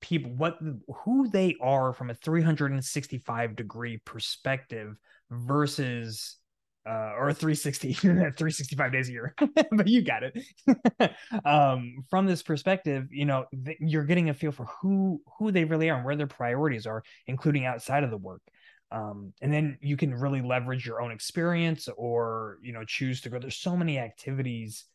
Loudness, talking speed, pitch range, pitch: -28 LUFS, 170 wpm, 120-160 Hz, 140 Hz